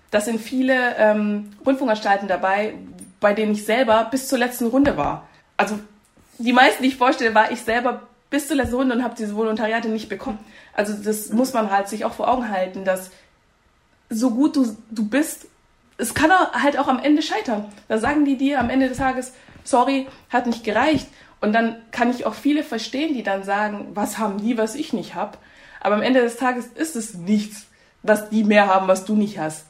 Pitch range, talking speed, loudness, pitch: 210-260 Hz, 205 wpm, -21 LUFS, 230 Hz